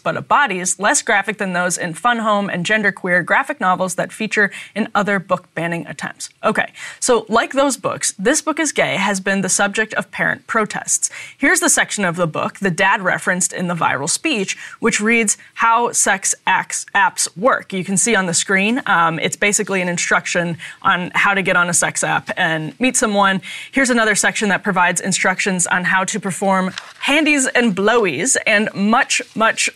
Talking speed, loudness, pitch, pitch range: 190 wpm, -16 LUFS, 200 Hz, 185-230 Hz